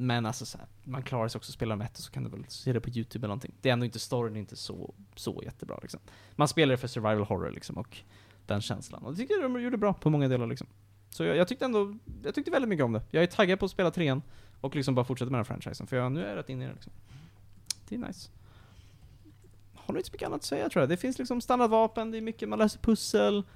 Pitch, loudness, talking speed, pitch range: 125 Hz, -31 LUFS, 290 wpm, 105-165 Hz